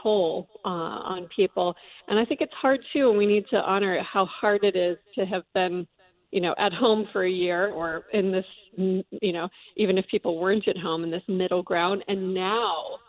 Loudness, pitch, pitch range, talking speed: -26 LUFS, 190 Hz, 180-205 Hz, 210 wpm